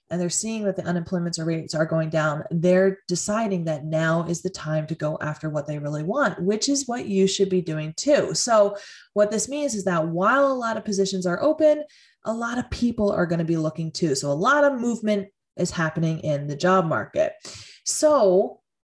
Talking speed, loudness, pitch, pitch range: 210 wpm, -23 LUFS, 185 Hz, 160-220 Hz